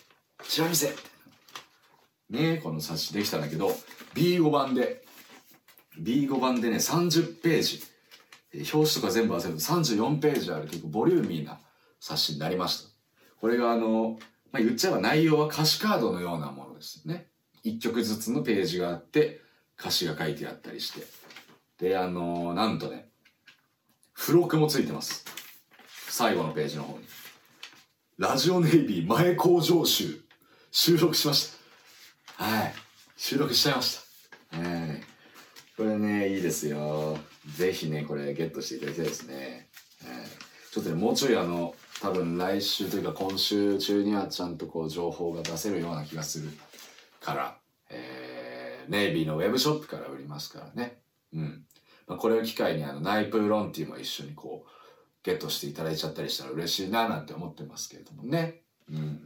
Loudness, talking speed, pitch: -28 LUFS, 335 characters per minute, 105 Hz